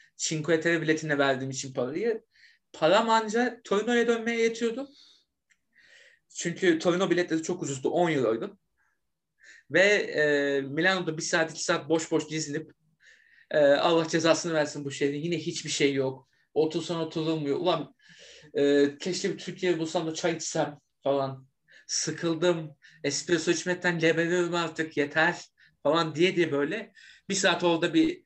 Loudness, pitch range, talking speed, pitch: -27 LUFS, 155-180 Hz, 140 wpm, 165 Hz